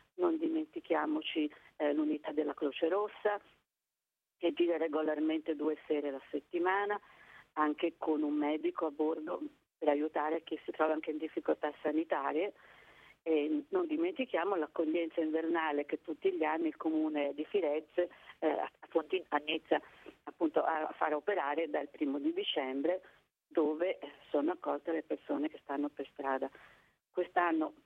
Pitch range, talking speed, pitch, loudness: 150-180 Hz, 140 wpm, 160 Hz, -35 LUFS